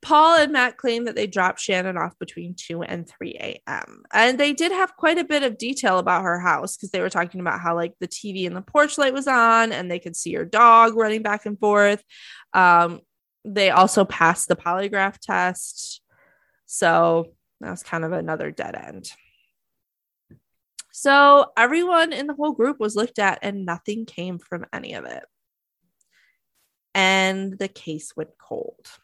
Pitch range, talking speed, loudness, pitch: 180-270 Hz, 180 wpm, -20 LUFS, 205 Hz